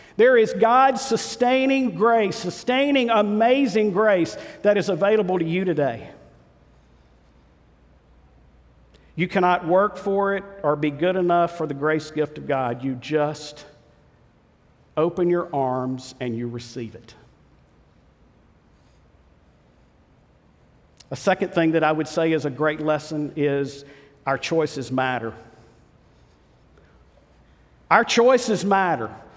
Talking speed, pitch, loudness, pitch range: 115 wpm, 155 Hz, -21 LUFS, 130-200 Hz